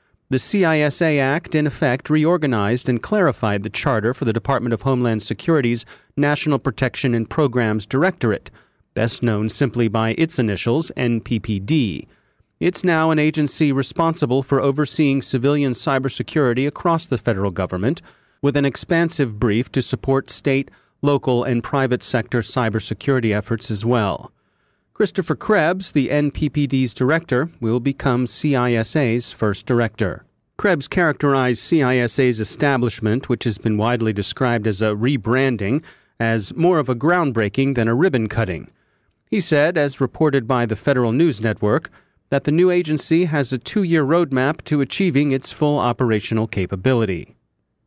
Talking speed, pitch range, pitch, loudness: 140 wpm, 115-150 Hz, 130 Hz, -19 LUFS